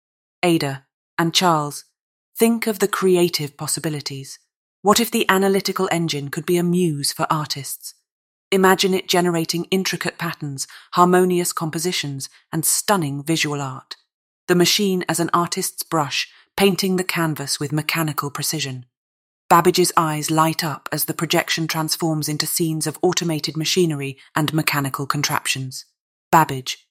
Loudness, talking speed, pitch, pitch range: -20 LUFS, 130 wpm, 160 Hz, 145-180 Hz